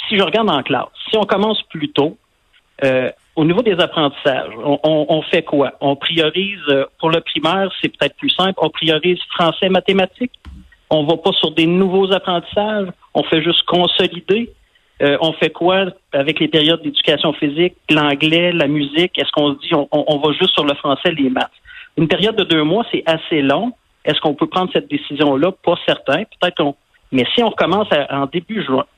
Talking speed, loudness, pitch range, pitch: 200 wpm, -16 LUFS, 150-190 Hz, 165 Hz